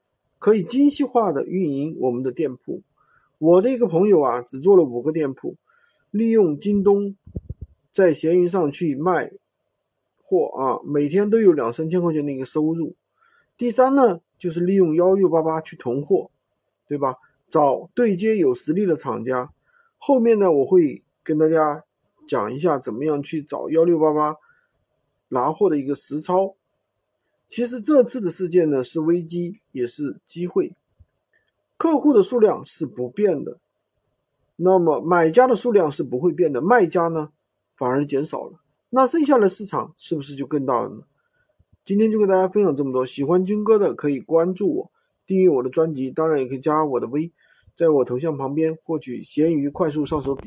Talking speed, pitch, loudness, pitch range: 255 characters per minute, 170 Hz, -20 LUFS, 150-215 Hz